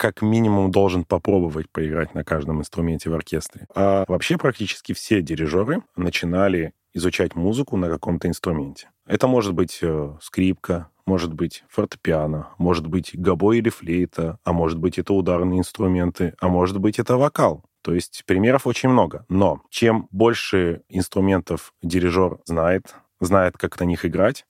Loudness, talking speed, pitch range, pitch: -21 LUFS, 145 wpm, 85-100 Hz, 90 Hz